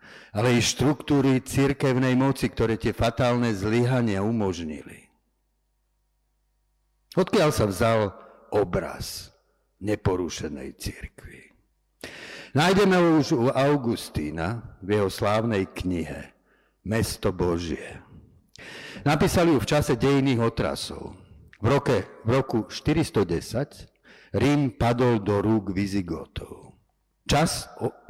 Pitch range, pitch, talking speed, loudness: 100-135 Hz, 115 Hz, 95 wpm, -24 LUFS